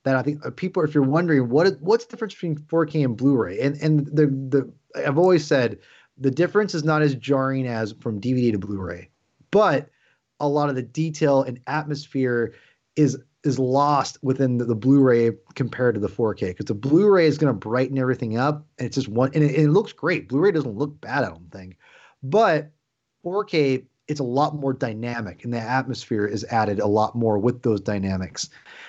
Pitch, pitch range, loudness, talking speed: 135 Hz, 120-150 Hz, -22 LUFS, 200 wpm